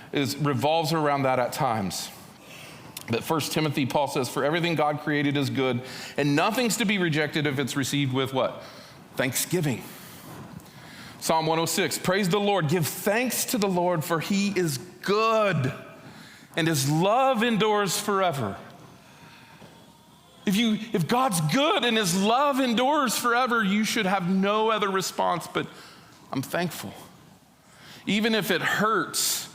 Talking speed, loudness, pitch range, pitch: 140 wpm, -25 LUFS, 150-210 Hz, 180 Hz